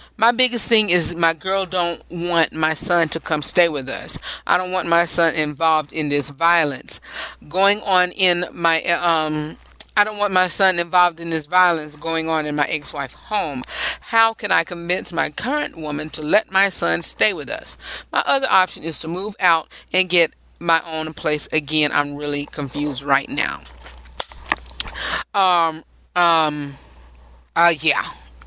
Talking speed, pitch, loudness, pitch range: 170 wpm, 165 Hz, -19 LUFS, 150-180 Hz